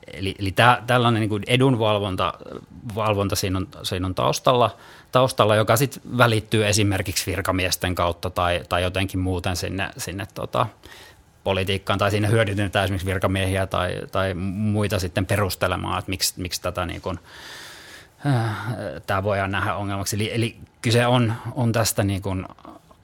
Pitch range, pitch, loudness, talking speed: 95-110 Hz, 100 Hz, -22 LUFS, 150 wpm